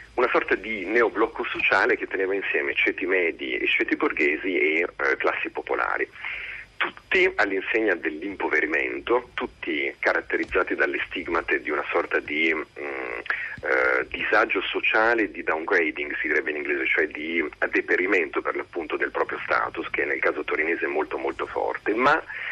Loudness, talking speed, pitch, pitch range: -24 LUFS, 145 wpm, 400 Hz, 360-440 Hz